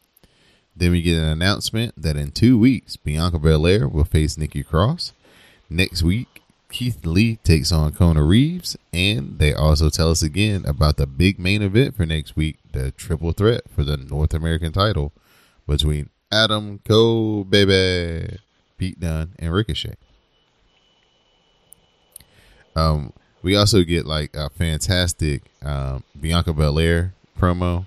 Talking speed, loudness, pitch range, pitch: 140 wpm, -20 LUFS, 75-100 Hz, 85 Hz